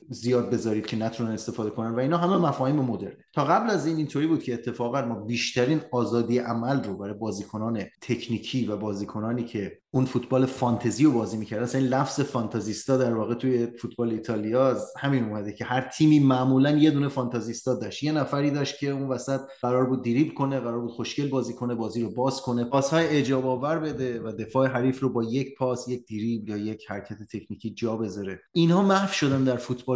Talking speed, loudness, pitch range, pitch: 195 wpm, -26 LUFS, 115-135 Hz, 125 Hz